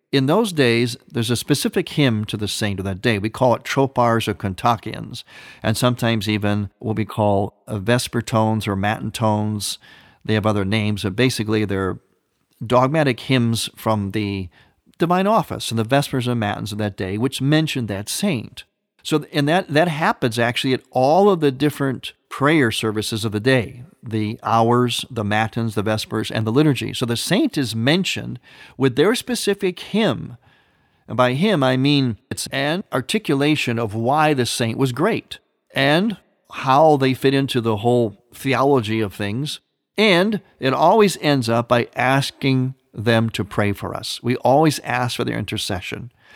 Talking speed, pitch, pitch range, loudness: 170 wpm, 120 Hz, 110-140 Hz, -20 LUFS